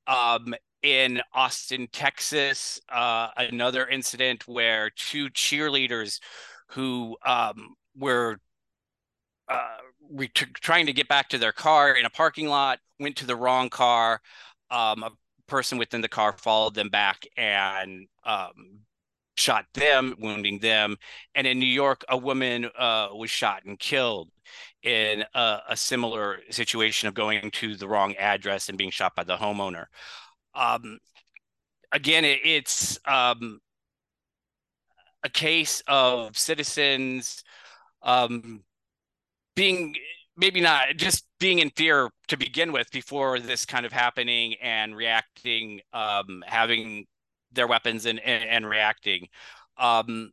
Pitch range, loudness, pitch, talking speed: 110-135 Hz, -24 LUFS, 120 Hz, 130 wpm